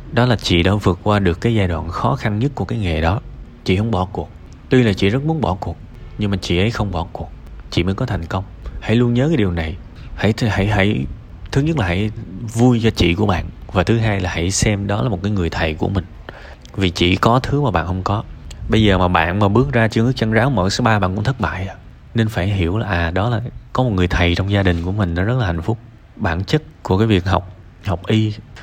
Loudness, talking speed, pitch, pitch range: -18 LUFS, 265 wpm, 100 Hz, 90-115 Hz